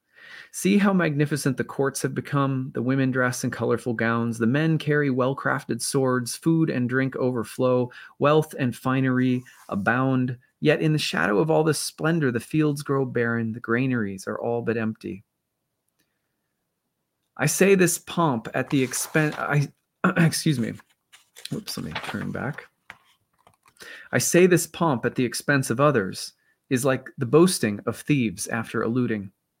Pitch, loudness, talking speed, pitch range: 130 Hz, -24 LUFS, 150 wpm, 120-155 Hz